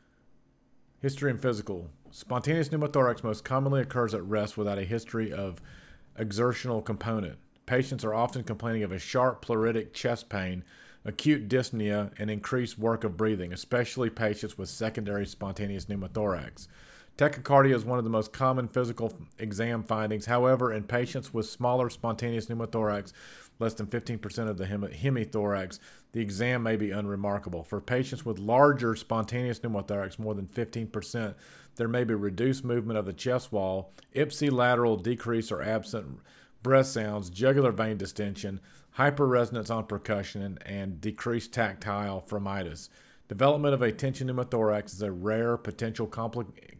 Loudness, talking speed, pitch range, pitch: -30 LUFS, 145 wpm, 105-125 Hz, 115 Hz